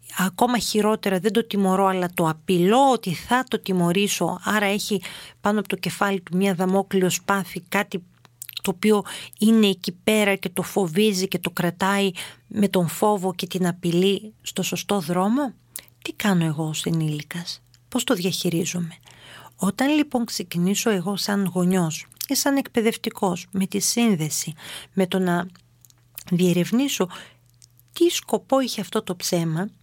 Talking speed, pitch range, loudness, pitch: 145 wpm, 175-210 Hz, -23 LUFS, 190 Hz